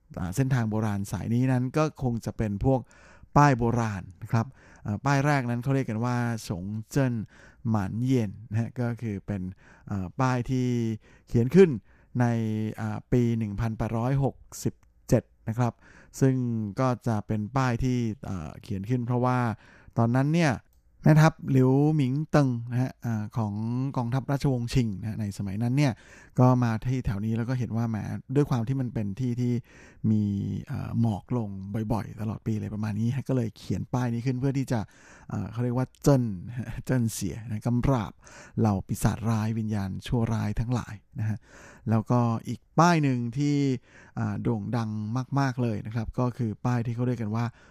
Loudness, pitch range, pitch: -27 LUFS, 110-130 Hz, 115 Hz